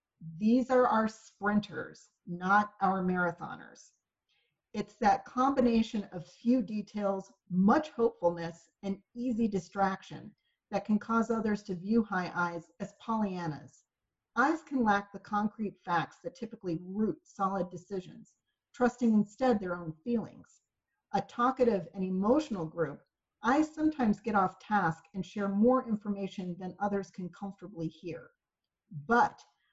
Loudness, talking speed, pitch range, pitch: -32 LUFS, 130 wpm, 185-230 Hz, 205 Hz